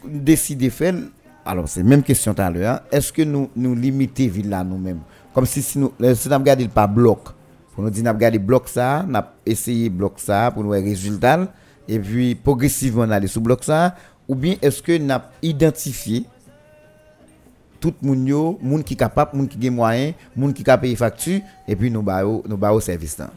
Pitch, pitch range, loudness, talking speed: 125 Hz, 105-140 Hz, -19 LUFS, 200 wpm